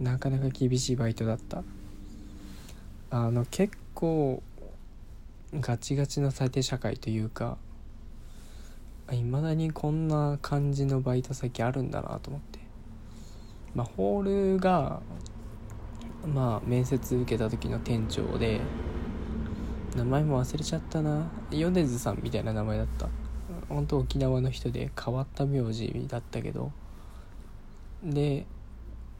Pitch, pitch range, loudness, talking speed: 125 Hz, 110-140 Hz, -30 LUFS, 235 characters per minute